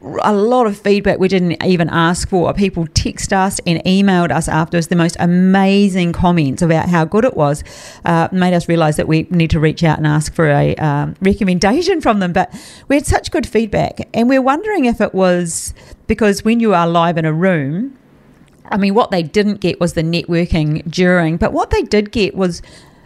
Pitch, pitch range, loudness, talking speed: 180 Hz, 165-205 Hz, -14 LUFS, 210 wpm